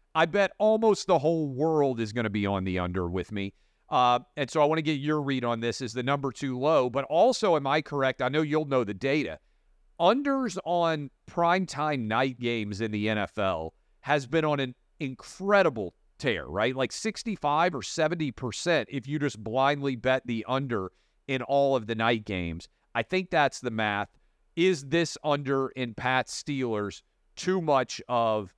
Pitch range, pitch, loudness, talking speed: 115-155 Hz, 135 Hz, -28 LUFS, 185 wpm